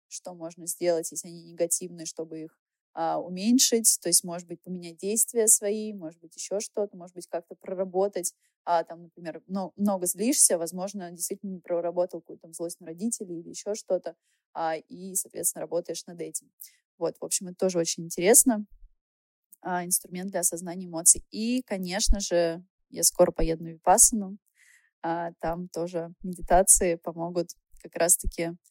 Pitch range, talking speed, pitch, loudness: 170-195 Hz, 155 wpm, 175 Hz, -25 LUFS